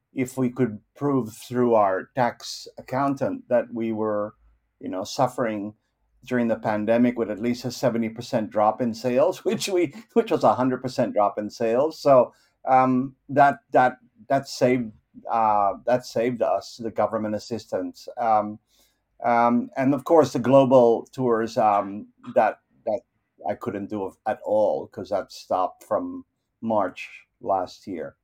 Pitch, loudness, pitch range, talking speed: 120 Hz, -23 LUFS, 110-135 Hz, 155 wpm